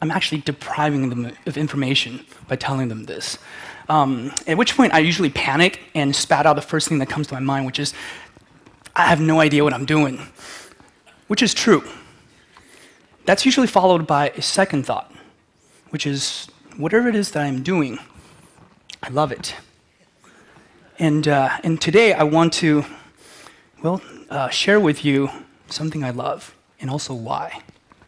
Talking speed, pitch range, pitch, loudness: 160 wpm, 140-165 Hz, 150 Hz, -19 LUFS